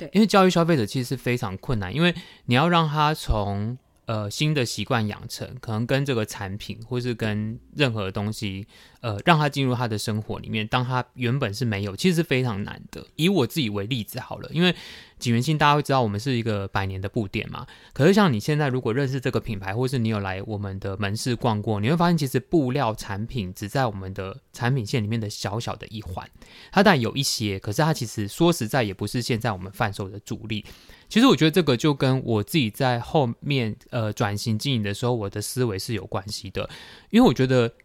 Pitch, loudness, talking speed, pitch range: 120 Hz, -24 LUFS, 335 characters per minute, 105-135 Hz